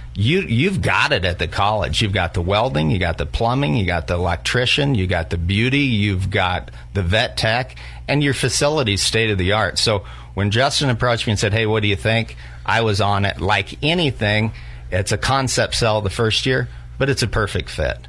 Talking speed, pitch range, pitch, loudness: 215 wpm, 90-120 Hz, 105 Hz, -18 LUFS